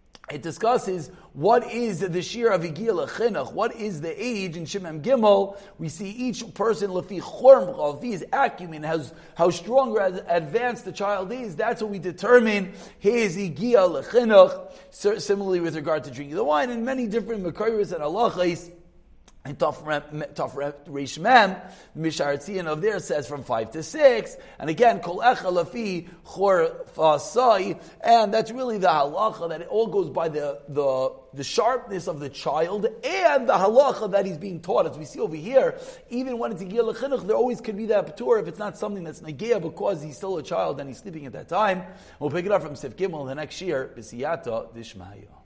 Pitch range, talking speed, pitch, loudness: 160-230 Hz, 180 wpm, 195 Hz, -24 LUFS